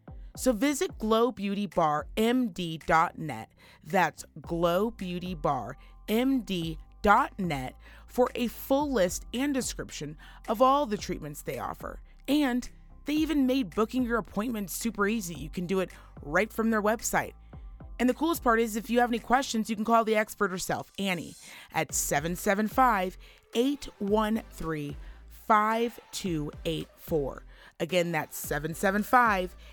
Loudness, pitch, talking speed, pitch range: -29 LUFS, 210 Hz, 120 wpm, 175-240 Hz